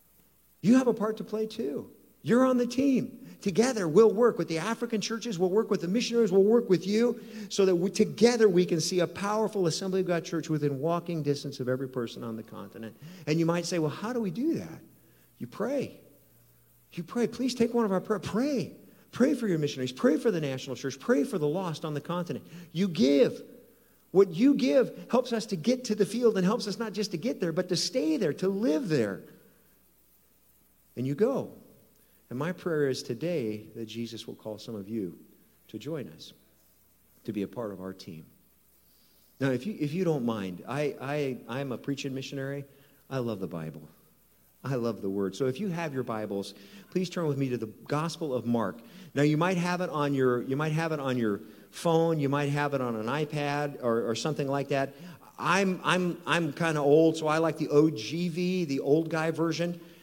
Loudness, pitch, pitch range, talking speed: -29 LUFS, 165 Hz, 135-205 Hz, 215 wpm